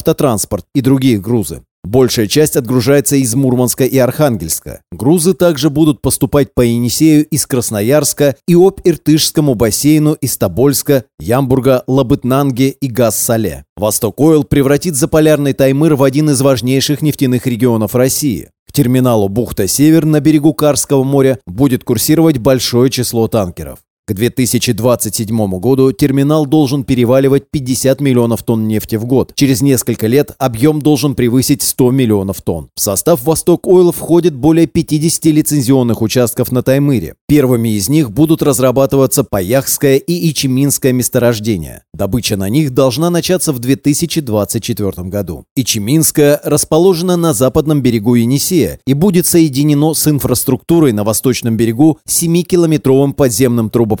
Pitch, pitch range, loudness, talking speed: 135 Hz, 120-150 Hz, -12 LUFS, 130 wpm